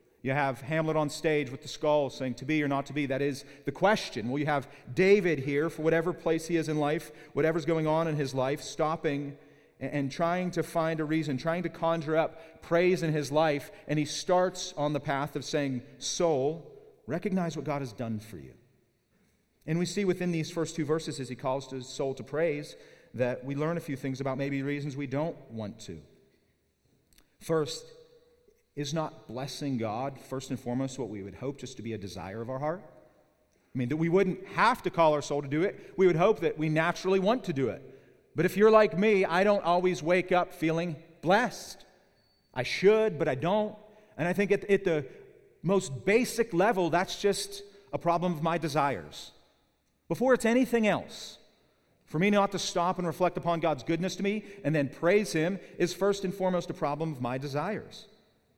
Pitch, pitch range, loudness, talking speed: 160 Hz, 140-185 Hz, -29 LUFS, 205 wpm